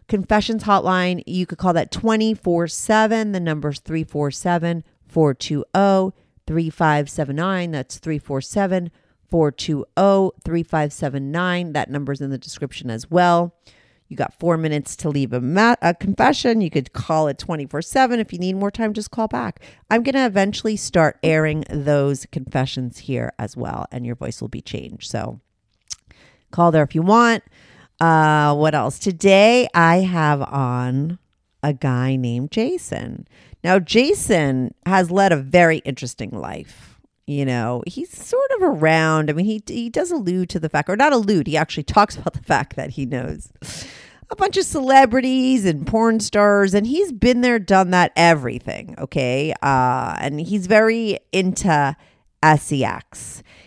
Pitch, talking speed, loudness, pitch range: 170 Hz, 150 wpm, -19 LUFS, 145-205 Hz